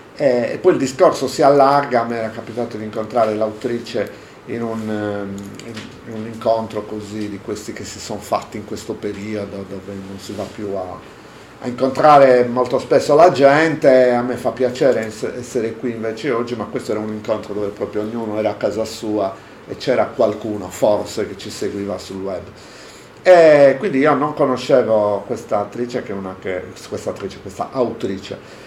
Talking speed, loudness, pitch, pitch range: 165 wpm, -18 LUFS, 110 Hz, 105-125 Hz